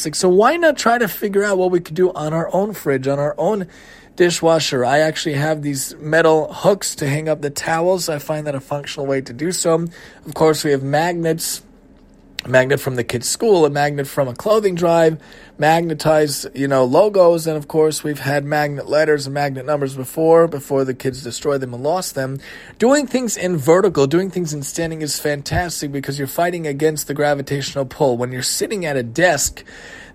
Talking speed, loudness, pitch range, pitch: 205 wpm, -18 LUFS, 140-170 Hz, 150 Hz